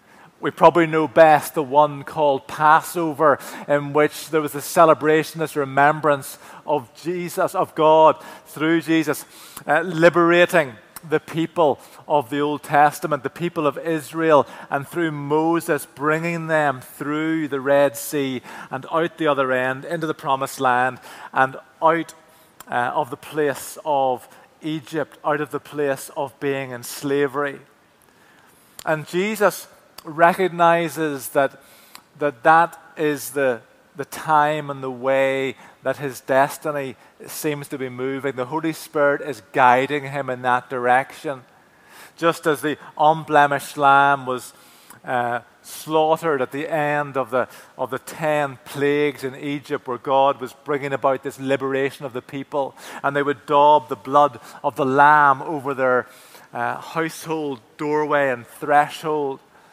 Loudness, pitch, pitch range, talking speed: -20 LUFS, 145 Hz, 135-155 Hz, 145 wpm